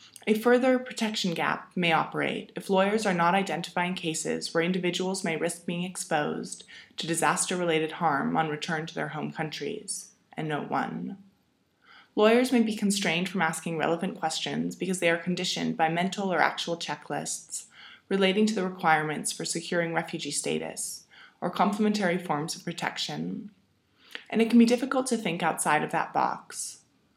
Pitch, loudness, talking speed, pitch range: 180 Hz, -28 LUFS, 155 wpm, 165-210 Hz